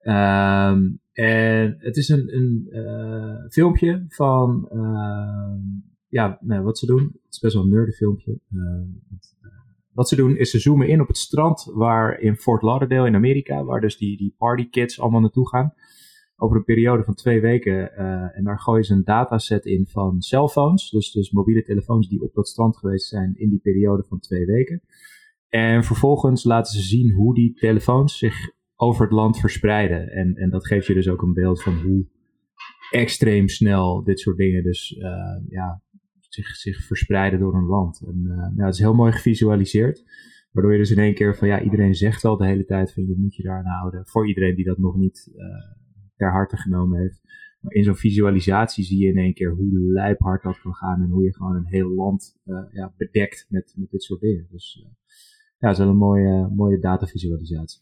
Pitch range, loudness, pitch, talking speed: 95-115 Hz, -20 LUFS, 100 Hz, 205 wpm